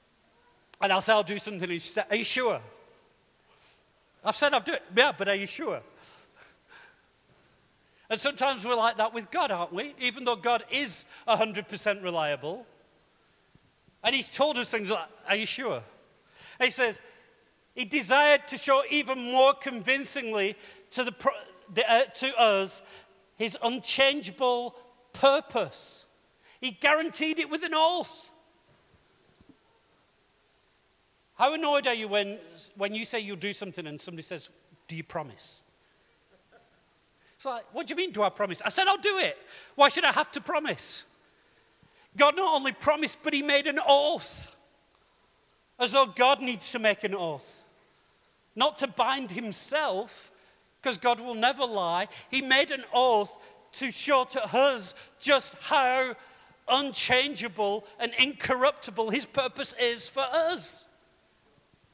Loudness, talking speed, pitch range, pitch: -27 LUFS, 145 wpm, 215-285 Hz, 255 Hz